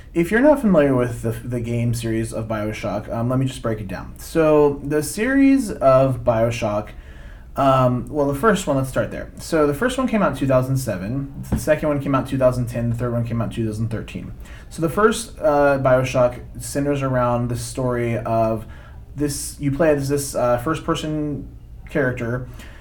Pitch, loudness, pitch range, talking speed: 130 Hz, -20 LUFS, 115-145 Hz, 190 wpm